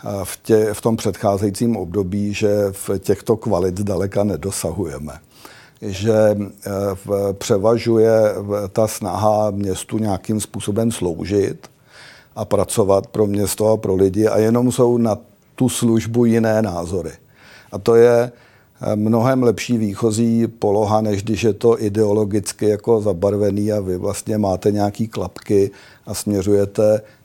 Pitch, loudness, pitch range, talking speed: 105 Hz, -18 LUFS, 100-115 Hz, 130 wpm